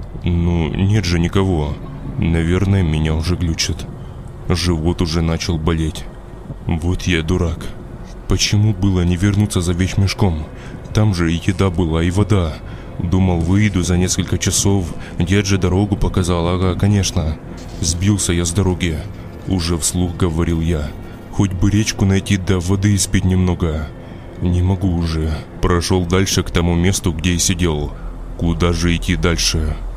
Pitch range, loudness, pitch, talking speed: 85-95 Hz, -17 LUFS, 90 Hz, 140 wpm